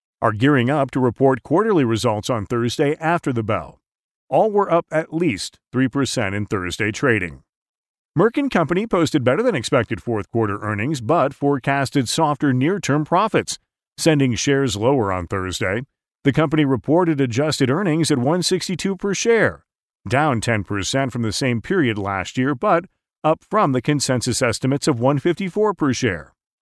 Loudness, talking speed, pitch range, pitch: -20 LUFS, 155 wpm, 115-160 Hz, 135 Hz